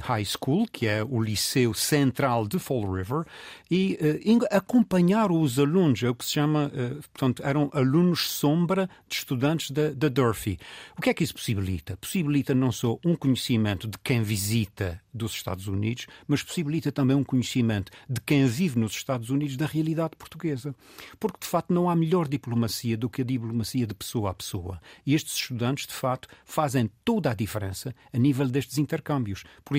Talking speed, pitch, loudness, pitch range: 180 wpm, 135 Hz, -26 LUFS, 115-150 Hz